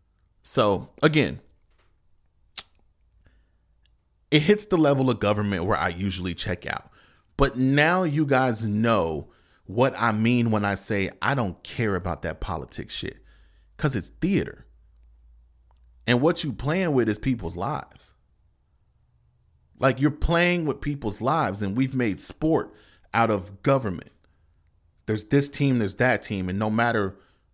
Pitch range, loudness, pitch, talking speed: 85-130 Hz, -24 LUFS, 105 Hz, 140 wpm